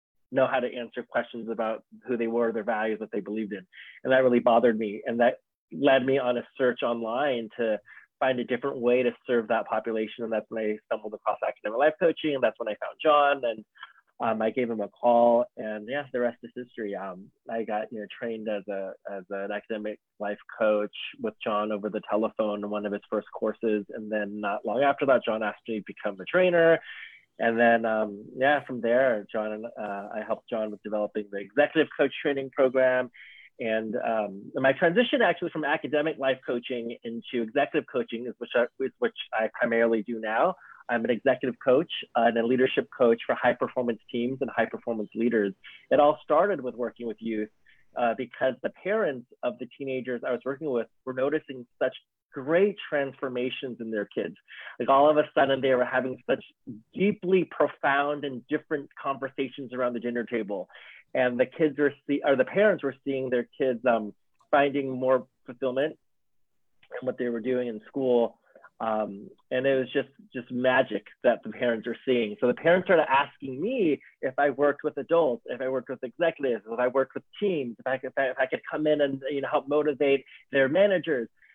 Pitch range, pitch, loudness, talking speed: 110-135 Hz, 125 Hz, -27 LUFS, 200 wpm